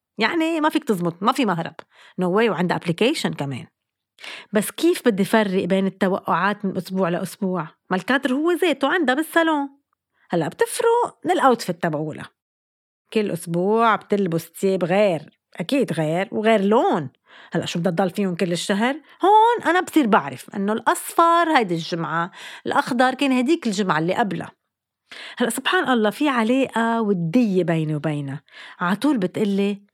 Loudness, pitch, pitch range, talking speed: -21 LUFS, 210 Hz, 180-270 Hz, 145 wpm